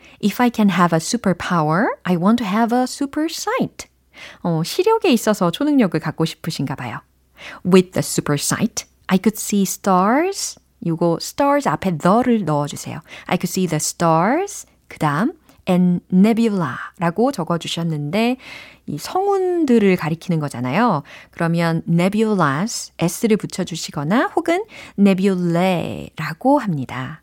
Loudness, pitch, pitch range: -19 LUFS, 185 Hz, 165-235 Hz